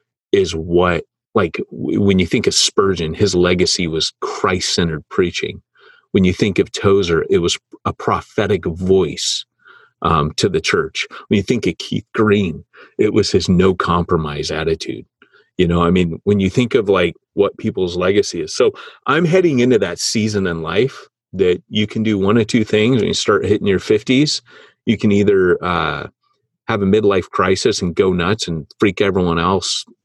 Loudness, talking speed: -16 LUFS, 175 wpm